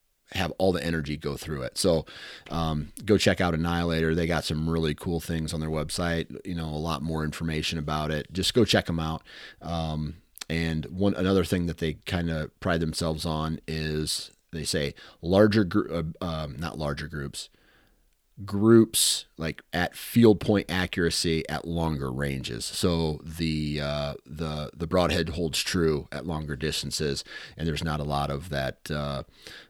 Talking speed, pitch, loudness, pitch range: 170 wpm, 80 Hz, -27 LUFS, 75-85 Hz